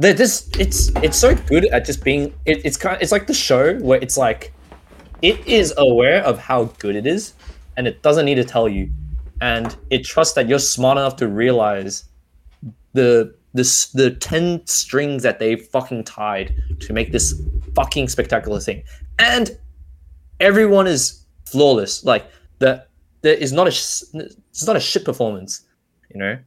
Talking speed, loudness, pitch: 165 wpm, -17 LUFS, 115 Hz